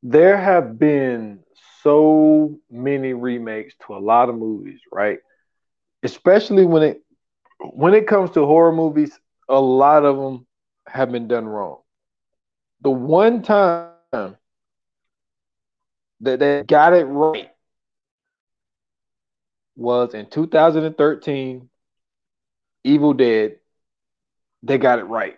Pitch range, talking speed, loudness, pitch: 125-160 Hz, 110 wpm, -17 LUFS, 145 Hz